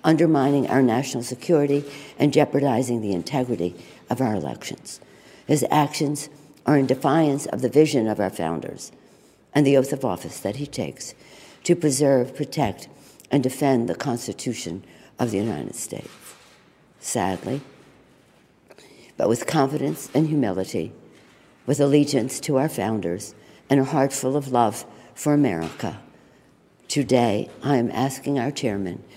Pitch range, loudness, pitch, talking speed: 110-145 Hz, -23 LUFS, 135 Hz, 135 wpm